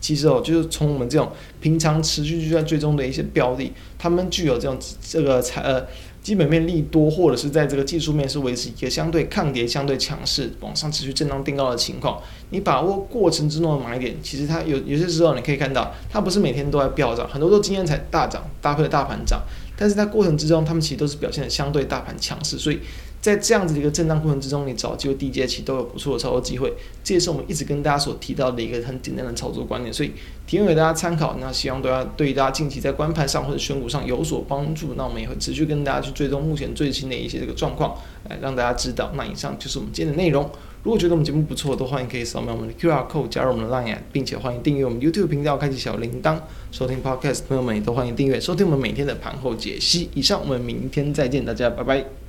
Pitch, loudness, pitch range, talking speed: 145 Hz, -22 LUFS, 130-160 Hz, 420 characters per minute